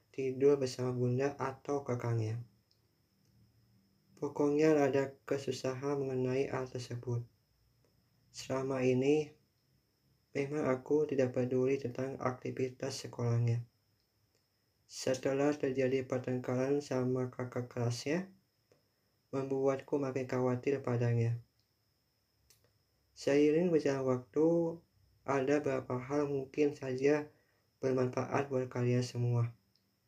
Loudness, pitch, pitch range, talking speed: -34 LUFS, 130 Hz, 120-140 Hz, 85 wpm